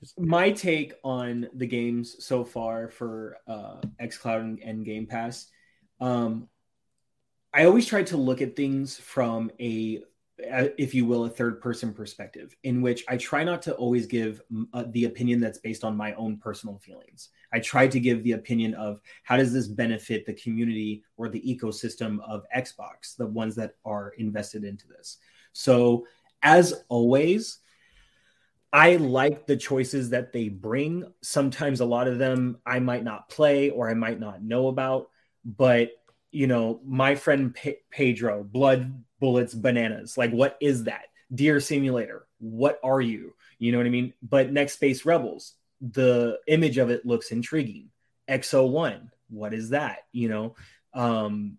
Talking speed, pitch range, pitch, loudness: 160 wpm, 115-135 Hz, 120 Hz, -25 LUFS